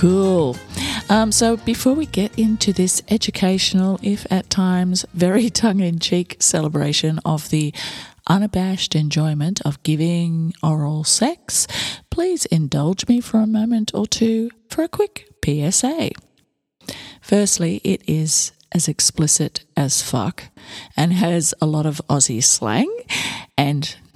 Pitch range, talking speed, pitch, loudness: 155-210 Hz, 130 wpm, 180 Hz, -18 LUFS